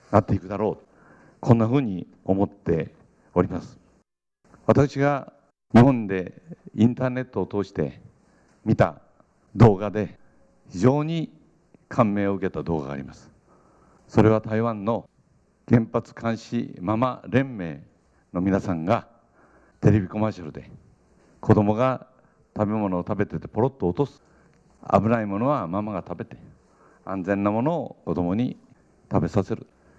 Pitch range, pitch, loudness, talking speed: 95-120 Hz, 105 Hz, -24 LUFS, 260 characters per minute